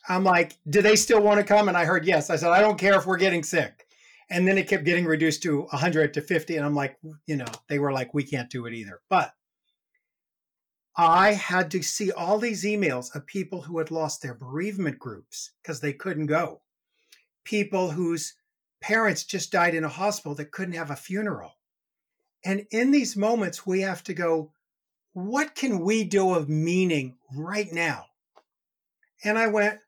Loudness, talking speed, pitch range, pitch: -25 LUFS, 195 wpm, 155-205 Hz, 180 Hz